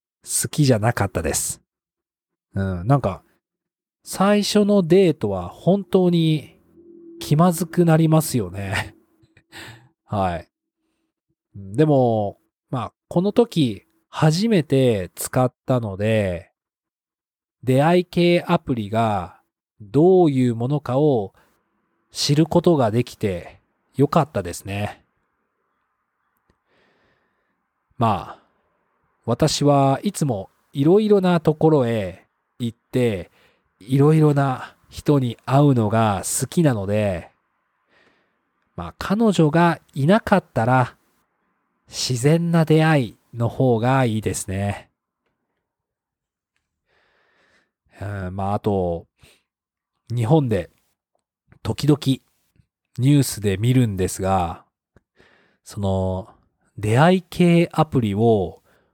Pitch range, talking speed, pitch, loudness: 105-160 Hz, 175 characters per minute, 130 Hz, -20 LUFS